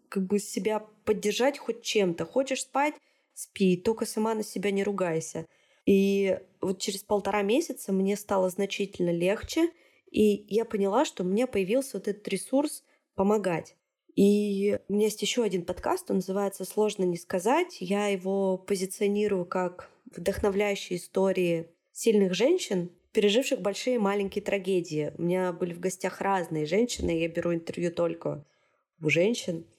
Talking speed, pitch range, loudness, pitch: 145 wpm, 185-225 Hz, -28 LUFS, 200 Hz